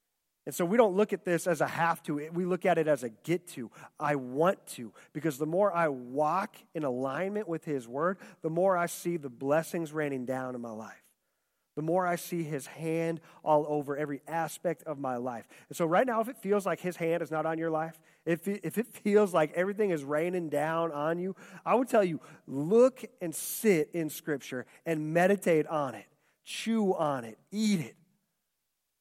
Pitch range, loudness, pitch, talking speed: 150-185 Hz, -31 LUFS, 165 Hz, 205 wpm